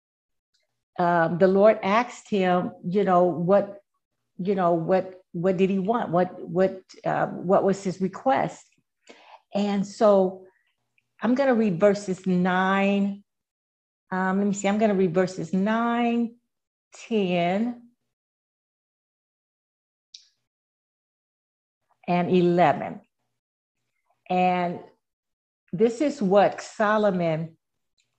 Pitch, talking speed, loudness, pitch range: 190 Hz, 100 wpm, -23 LUFS, 180-210 Hz